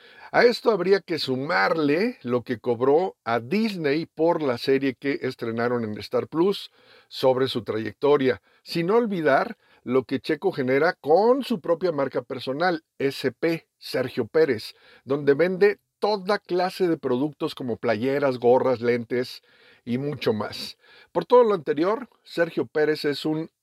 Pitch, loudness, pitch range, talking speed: 145 Hz, -24 LUFS, 130-180 Hz, 140 wpm